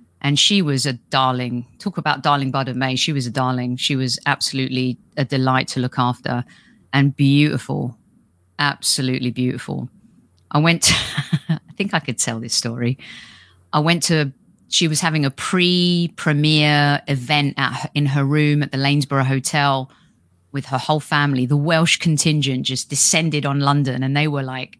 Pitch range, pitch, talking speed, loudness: 130-150 Hz, 140 Hz, 170 wpm, -18 LUFS